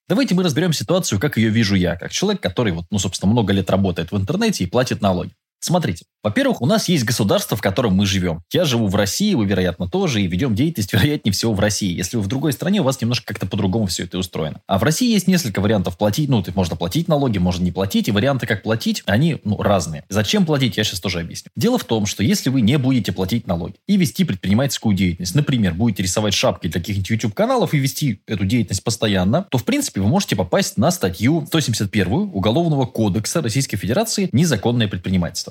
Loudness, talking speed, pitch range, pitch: -19 LUFS, 220 wpm, 95-140 Hz, 110 Hz